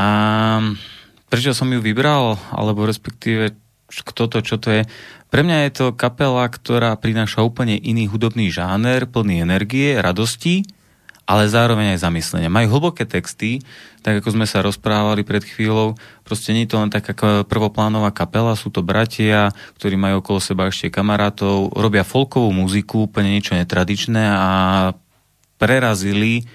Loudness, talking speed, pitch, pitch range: -18 LUFS, 145 wpm, 110 Hz, 100-115 Hz